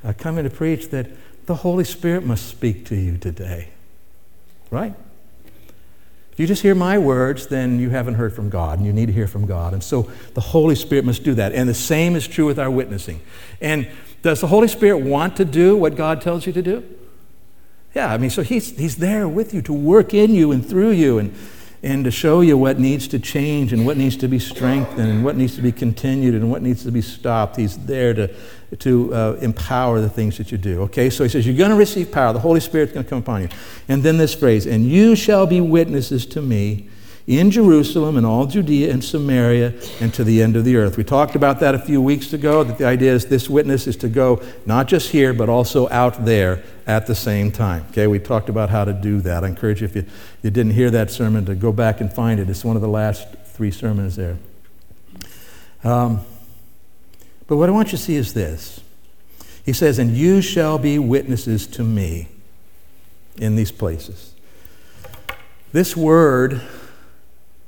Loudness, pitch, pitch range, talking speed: -18 LUFS, 125 Hz, 110-150 Hz, 215 wpm